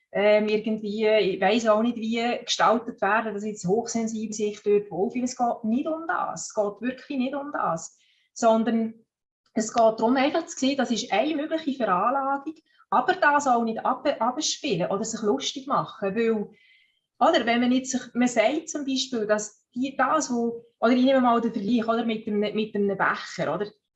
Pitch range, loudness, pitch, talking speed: 215-265 Hz, -25 LUFS, 230 Hz, 190 wpm